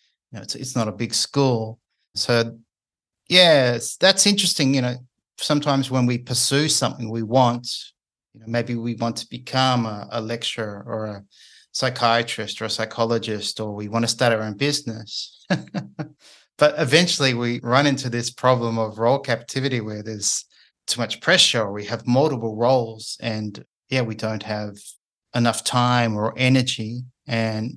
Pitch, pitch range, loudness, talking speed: 120 Hz, 110-130 Hz, -21 LUFS, 160 wpm